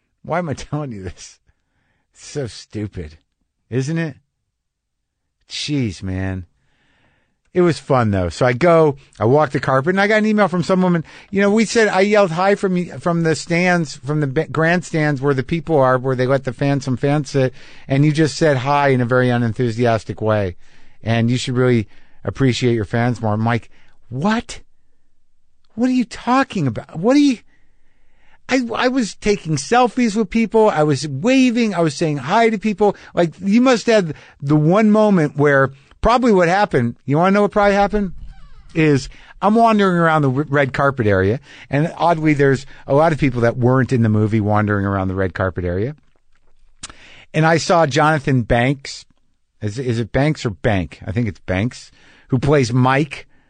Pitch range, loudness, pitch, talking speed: 120-180 Hz, -17 LUFS, 145 Hz, 185 wpm